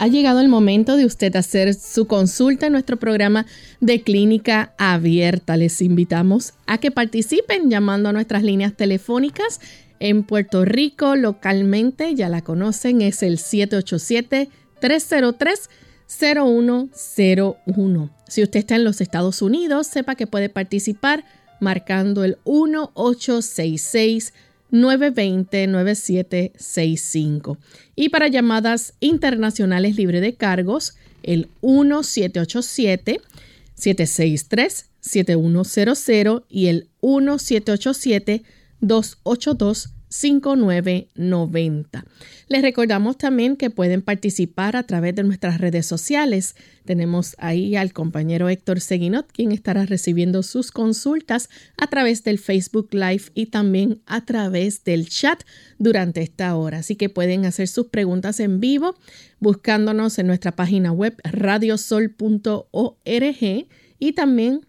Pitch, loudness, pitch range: 210 Hz, -19 LUFS, 185-245 Hz